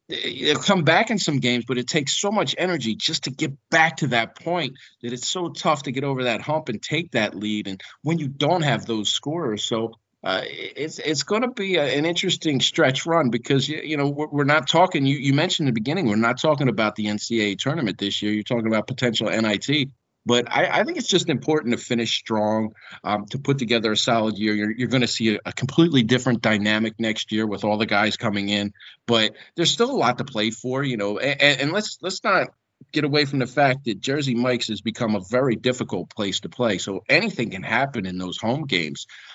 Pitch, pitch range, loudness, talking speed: 125 Hz, 110-155 Hz, -22 LUFS, 230 wpm